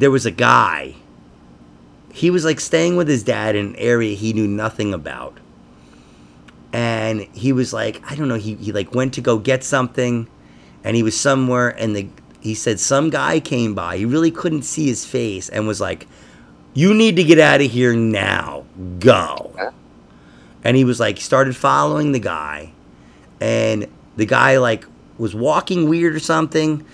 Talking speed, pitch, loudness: 180 wpm, 110 Hz, -17 LUFS